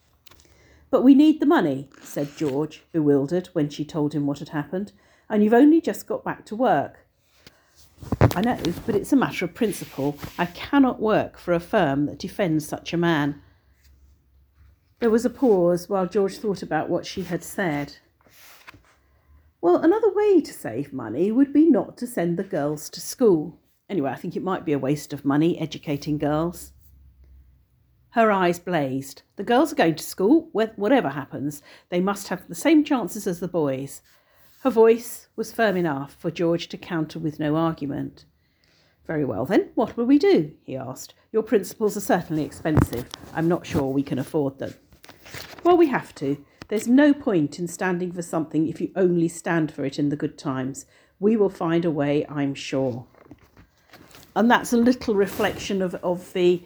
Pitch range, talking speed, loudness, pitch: 145-220 Hz, 180 wpm, -23 LUFS, 170 Hz